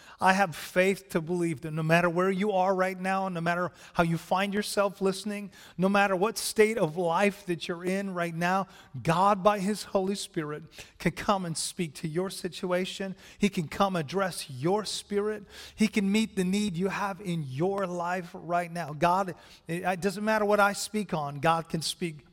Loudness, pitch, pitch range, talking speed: -28 LUFS, 185 Hz, 175-200 Hz, 195 wpm